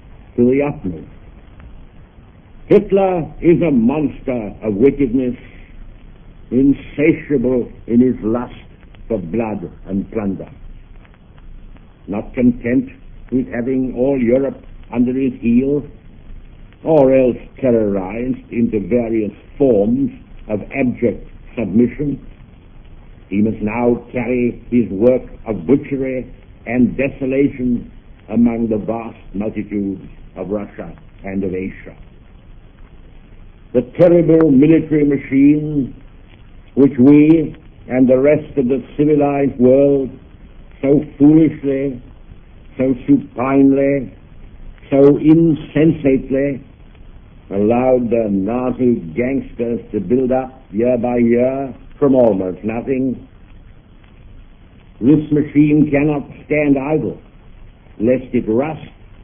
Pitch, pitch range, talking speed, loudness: 125 Hz, 105-140 Hz, 95 wpm, -16 LUFS